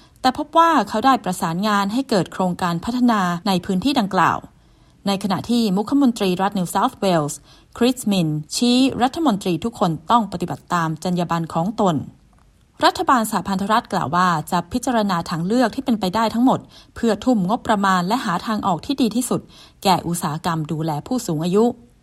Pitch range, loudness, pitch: 175-240 Hz, -20 LUFS, 200 Hz